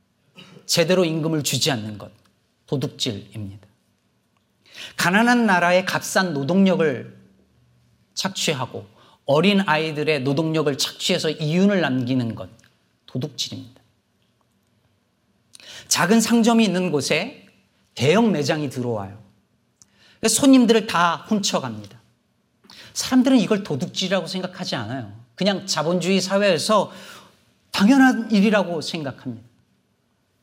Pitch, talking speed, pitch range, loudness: 160 Hz, 255 characters per minute, 120-195 Hz, -20 LUFS